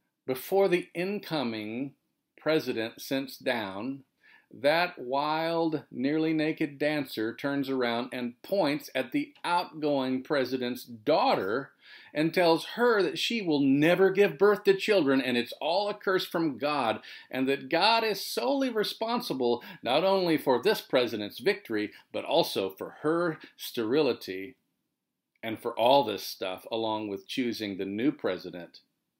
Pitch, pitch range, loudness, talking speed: 150 Hz, 125-185 Hz, -28 LUFS, 135 wpm